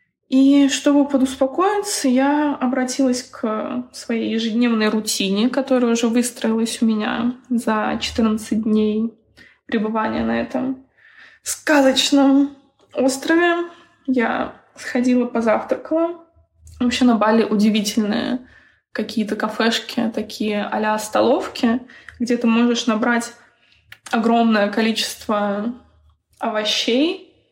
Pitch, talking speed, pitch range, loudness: 240 Hz, 90 wpm, 220-270 Hz, -19 LUFS